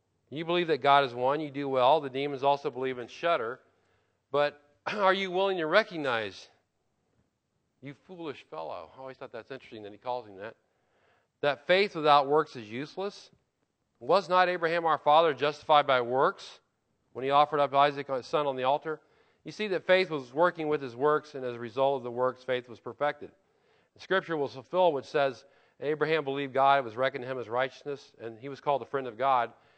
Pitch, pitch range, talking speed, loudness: 140 Hz, 130-155 Hz, 205 wpm, -28 LUFS